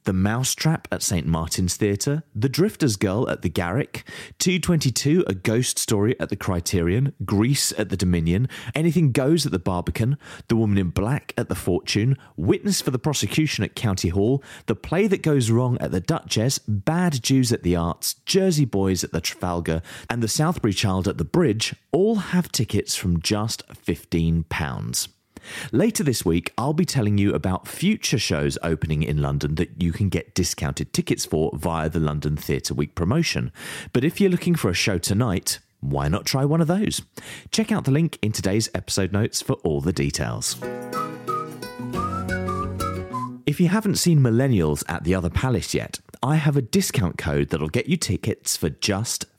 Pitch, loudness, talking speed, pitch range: 105 Hz, -23 LUFS, 180 wpm, 90-140 Hz